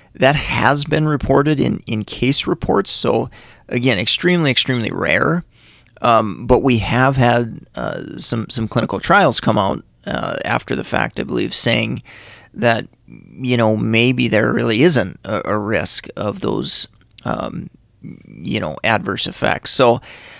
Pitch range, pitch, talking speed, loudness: 115-135 Hz, 125 Hz, 145 wpm, -16 LUFS